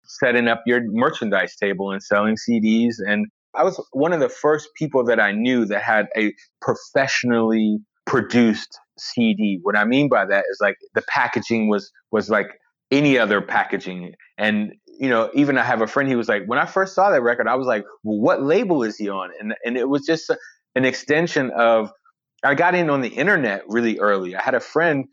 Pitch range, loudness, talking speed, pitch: 105-140 Hz, -20 LUFS, 210 wpm, 115 Hz